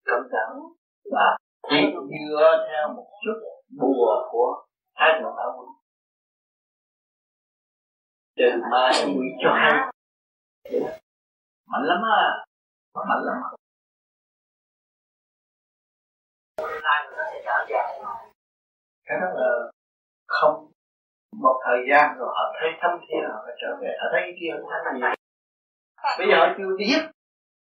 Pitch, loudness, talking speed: 150 Hz, -23 LUFS, 100 wpm